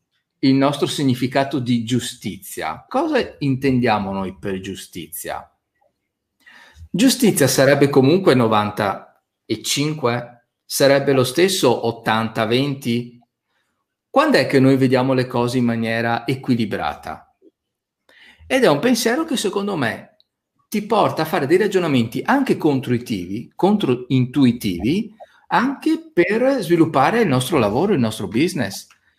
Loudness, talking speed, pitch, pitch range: -18 LUFS, 110 wpm, 135 Hz, 120-180 Hz